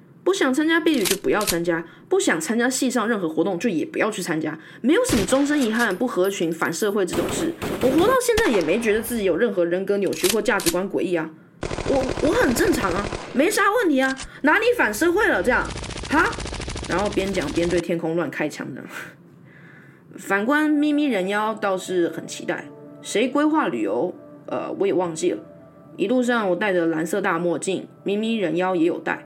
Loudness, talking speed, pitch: -22 LUFS, 290 characters per minute, 210 Hz